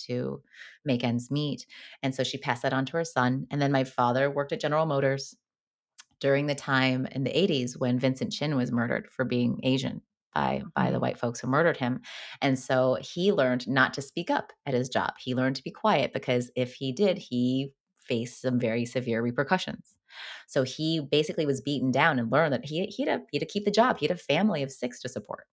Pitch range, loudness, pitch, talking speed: 125-150 Hz, -28 LUFS, 135 Hz, 220 wpm